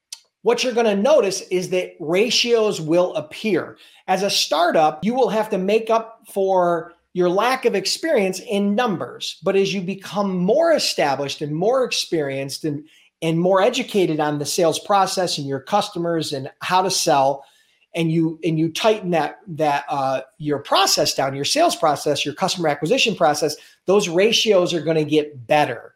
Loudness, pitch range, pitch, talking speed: -20 LUFS, 155-205 Hz, 180 Hz, 175 wpm